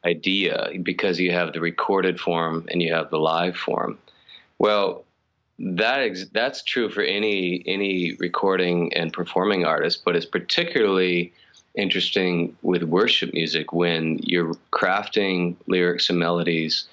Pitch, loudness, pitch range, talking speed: 85 Hz, -22 LUFS, 85-90 Hz, 135 wpm